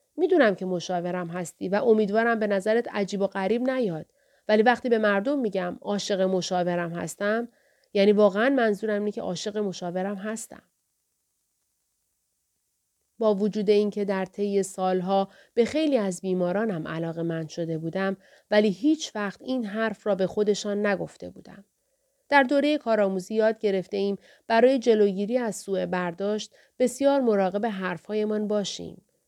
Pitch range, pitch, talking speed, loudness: 190-225 Hz, 205 Hz, 135 wpm, -25 LUFS